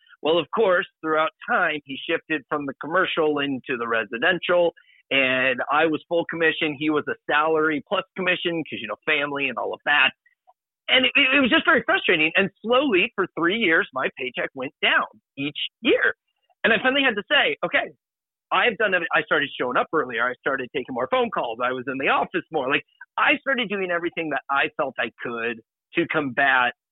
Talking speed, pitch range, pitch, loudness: 195 wpm, 140-235 Hz, 165 Hz, -22 LUFS